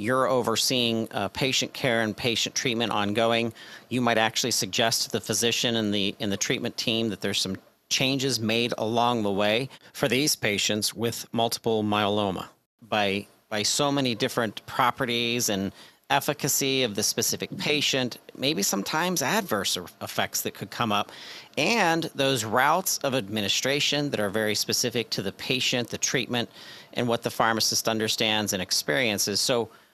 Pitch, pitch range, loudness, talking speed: 115 Hz, 105-130 Hz, -25 LUFS, 155 wpm